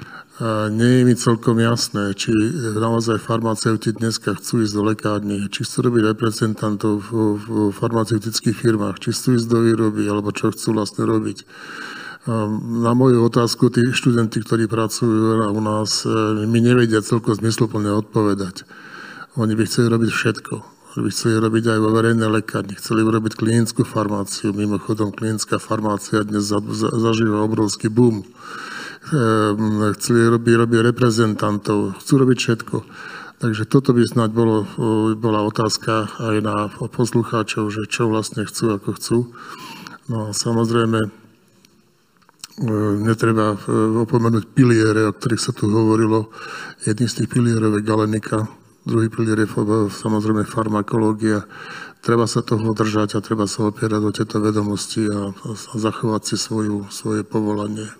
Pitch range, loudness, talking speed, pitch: 105-115 Hz, -19 LUFS, 135 wpm, 110 Hz